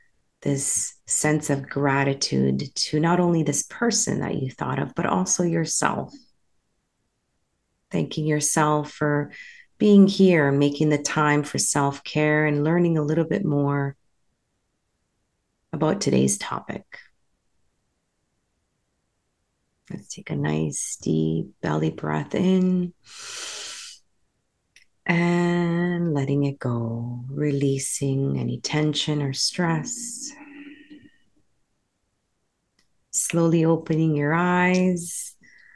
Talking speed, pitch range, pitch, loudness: 95 wpm, 140-175 Hz, 155 Hz, -23 LUFS